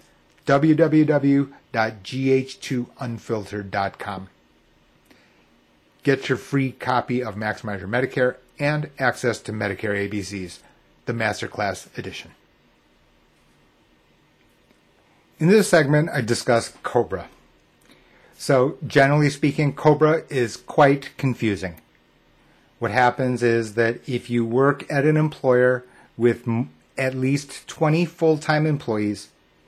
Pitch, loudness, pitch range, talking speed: 125 Hz, -22 LUFS, 105-140 Hz, 95 wpm